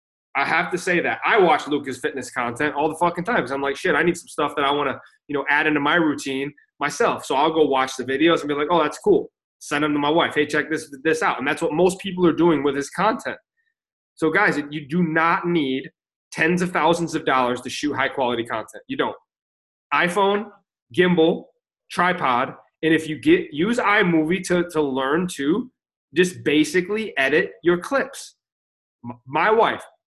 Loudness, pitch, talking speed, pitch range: -21 LUFS, 155 Hz, 205 wpm, 140-175 Hz